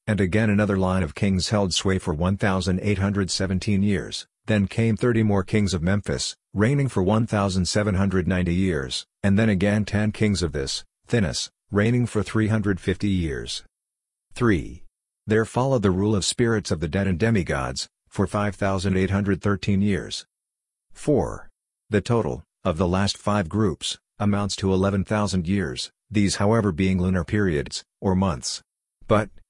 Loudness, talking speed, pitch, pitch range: -23 LUFS, 140 wpm, 100 Hz, 95-105 Hz